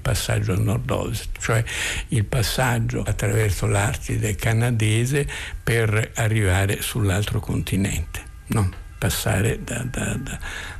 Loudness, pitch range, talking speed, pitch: -23 LUFS, 100-115 Hz, 100 wpm, 110 Hz